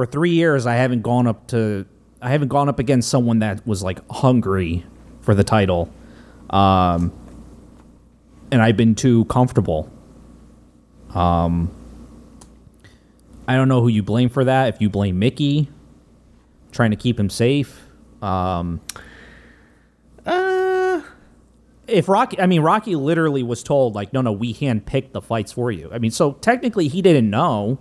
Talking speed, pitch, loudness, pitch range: 155 wpm, 120 Hz, -19 LUFS, 100-140 Hz